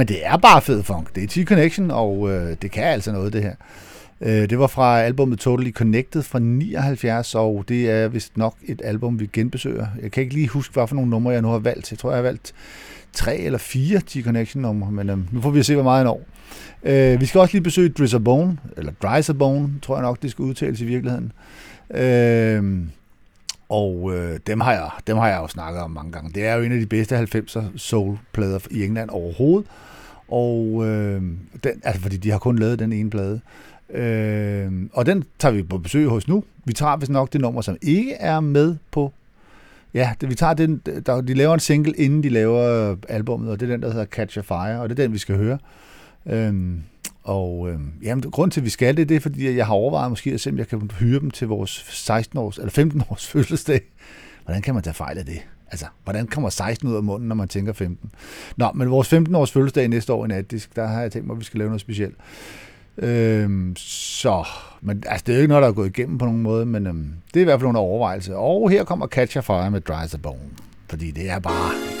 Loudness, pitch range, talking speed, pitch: -21 LUFS, 100-135 Hz, 235 wpm, 115 Hz